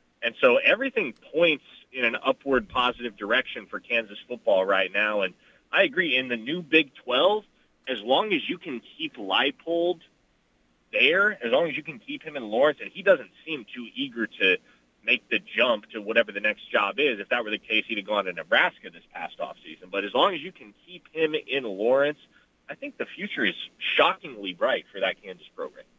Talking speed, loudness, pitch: 205 wpm, -25 LUFS, 165 Hz